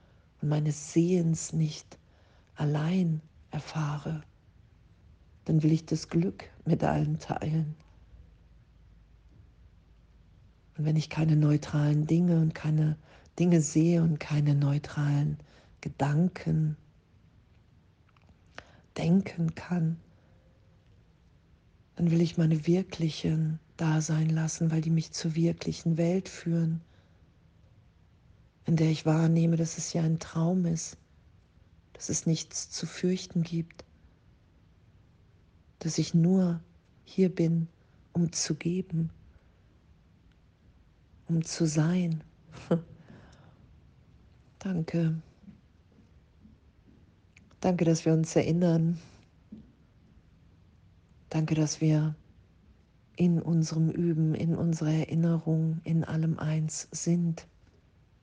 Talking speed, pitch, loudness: 95 wpm, 155 Hz, -29 LUFS